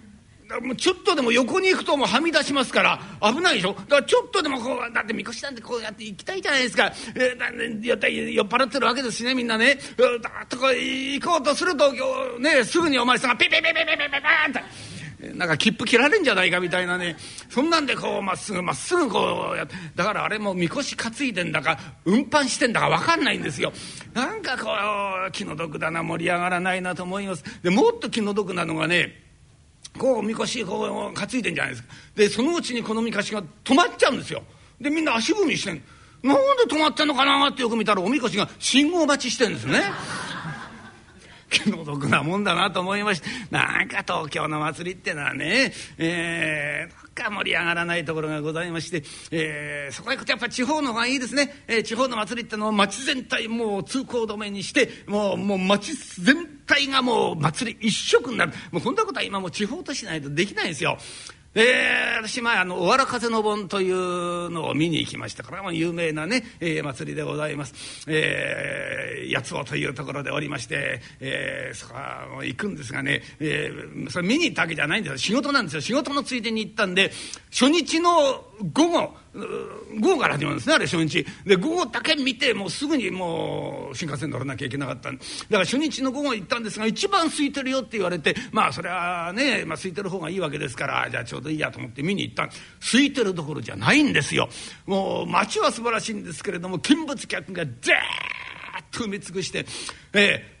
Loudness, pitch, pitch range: -23 LUFS, 220 Hz, 175-270 Hz